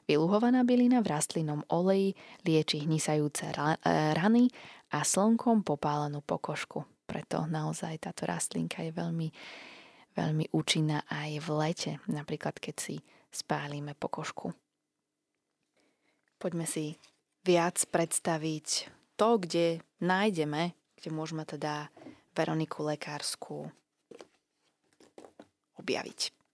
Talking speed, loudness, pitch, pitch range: 95 wpm, -31 LUFS, 160 Hz, 150-190 Hz